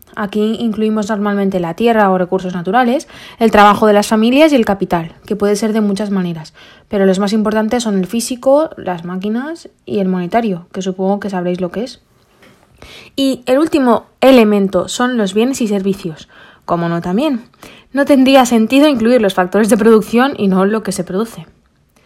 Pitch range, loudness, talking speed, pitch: 190-240 Hz, -13 LUFS, 180 wpm, 210 Hz